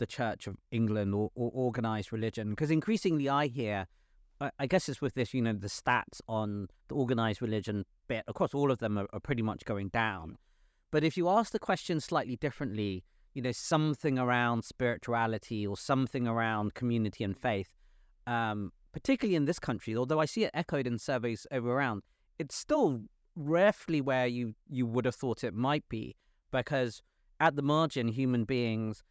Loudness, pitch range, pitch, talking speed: -32 LUFS, 110-140 Hz, 125 Hz, 180 wpm